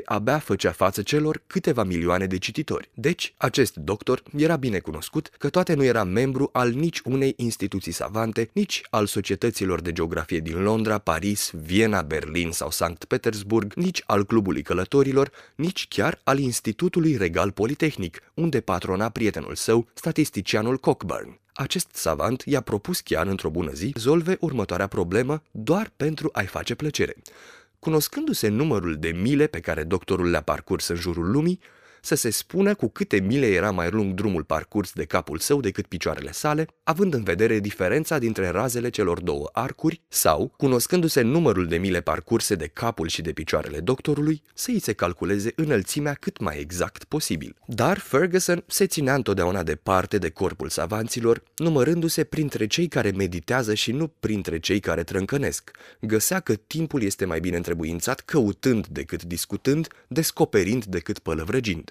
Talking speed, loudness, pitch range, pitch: 155 wpm, -24 LUFS, 95-150 Hz, 115 Hz